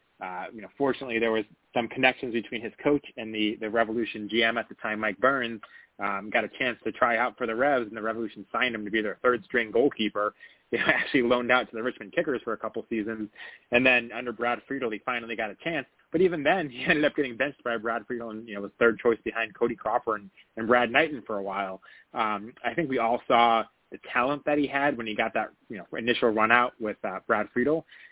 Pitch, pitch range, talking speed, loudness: 115 Hz, 110-125 Hz, 245 wpm, -27 LUFS